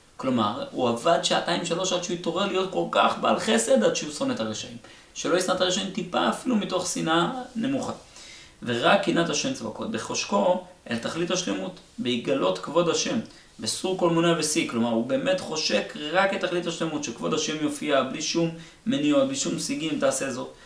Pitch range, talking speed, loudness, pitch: 155-200 Hz, 175 wpm, -25 LUFS, 180 Hz